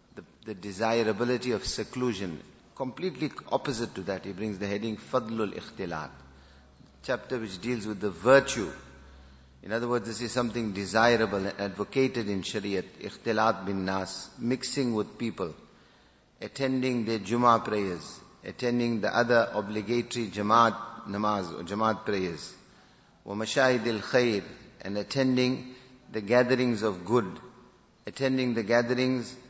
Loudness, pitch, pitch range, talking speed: -29 LUFS, 110 Hz, 100-125 Hz, 125 wpm